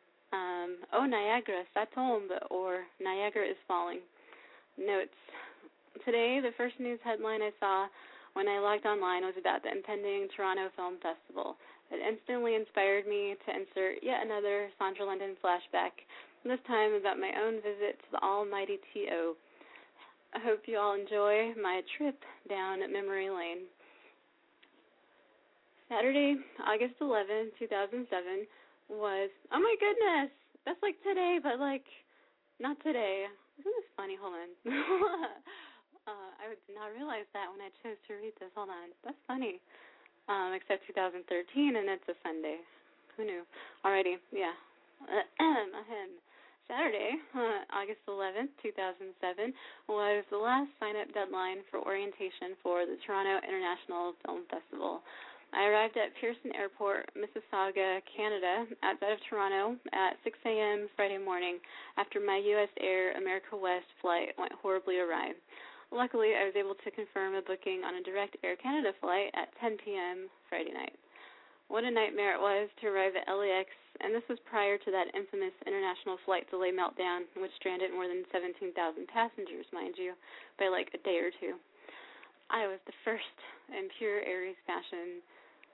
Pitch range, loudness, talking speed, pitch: 190-245 Hz, -35 LUFS, 150 wpm, 205 Hz